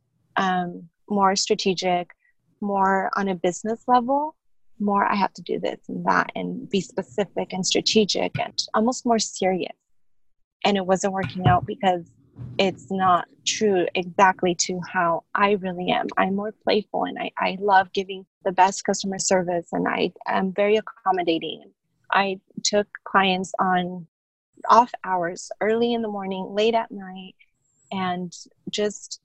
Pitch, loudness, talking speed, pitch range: 190 Hz, -23 LUFS, 150 wpm, 180-205 Hz